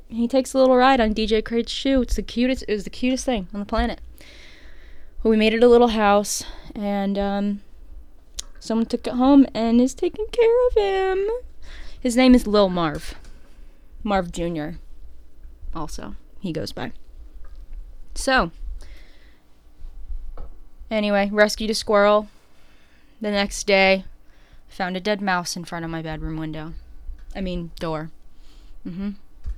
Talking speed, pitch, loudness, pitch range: 145 wpm, 200 Hz, -21 LUFS, 150-235 Hz